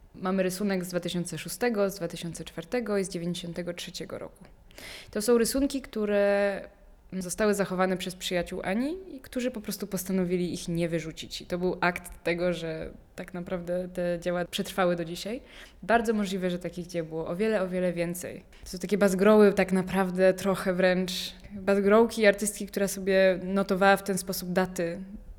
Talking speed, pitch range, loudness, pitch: 160 wpm, 175-200 Hz, -28 LUFS, 185 Hz